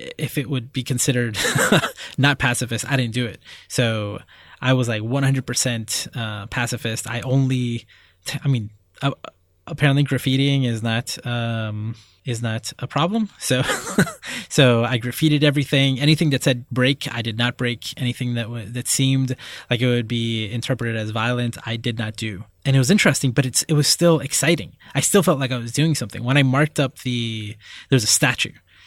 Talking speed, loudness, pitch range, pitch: 185 wpm, -21 LUFS, 115-140 Hz, 125 Hz